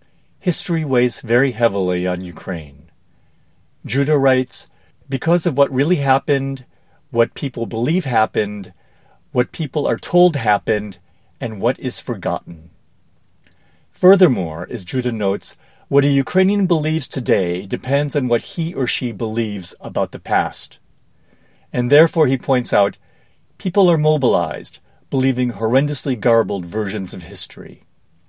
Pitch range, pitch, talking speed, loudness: 105-145 Hz, 130 Hz, 125 wpm, -18 LUFS